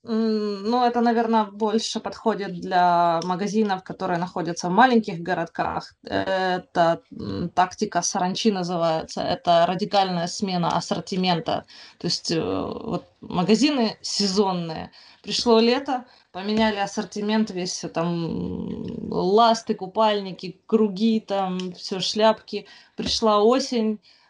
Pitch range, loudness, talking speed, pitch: 180-220 Hz, -23 LUFS, 95 wpm, 200 Hz